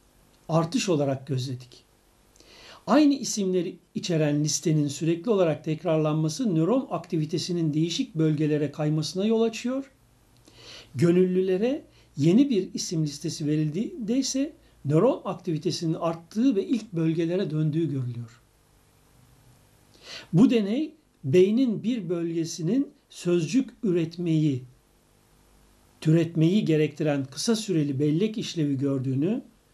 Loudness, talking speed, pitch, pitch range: -25 LUFS, 95 wpm, 165 Hz, 150-205 Hz